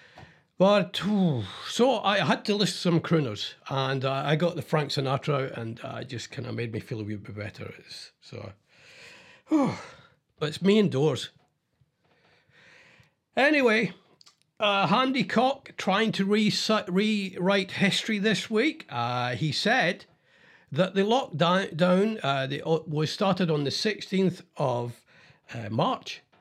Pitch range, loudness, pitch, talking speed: 140-205 Hz, -26 LUFS, 175 Hz, 140 wpm